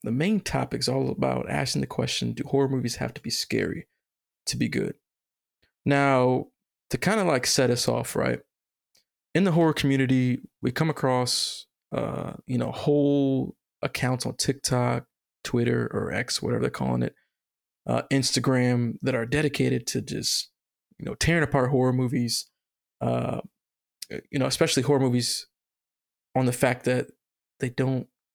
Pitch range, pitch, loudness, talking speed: 120-140 Hz, 130 Hz, -26 LUFS, 155 wpm